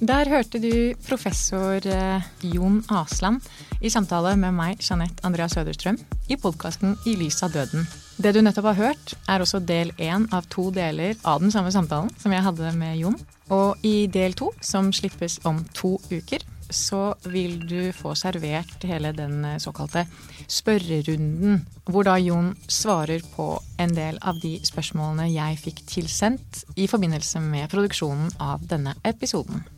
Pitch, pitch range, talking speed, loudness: 185 Hz, 165-200 Hz, 155 wpm, -24 LUFS